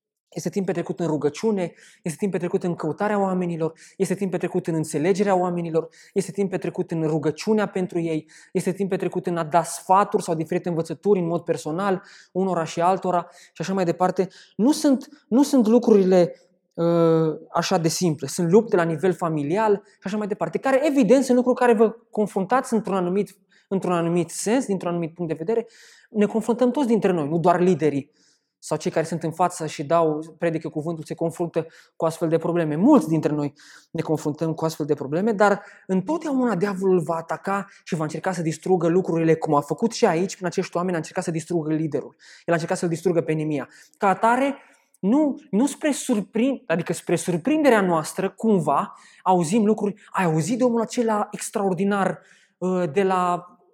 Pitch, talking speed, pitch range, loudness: 180 Hz, 185 wpm, 165-205 Hz, -23 LUFS